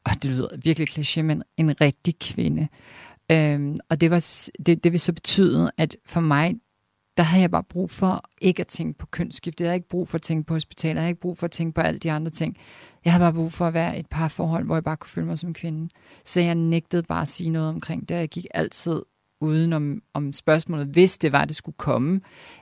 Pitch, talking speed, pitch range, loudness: 165 Hz, 250 wpm, 155-175 Hz, -23 LUFS